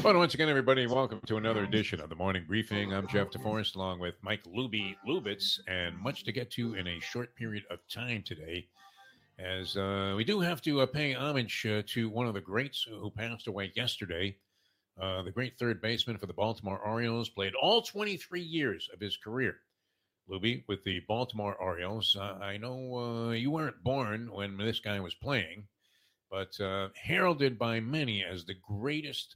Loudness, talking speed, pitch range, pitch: -33 LUFS, 190 wpm, 100-125 Hz, 110 Hz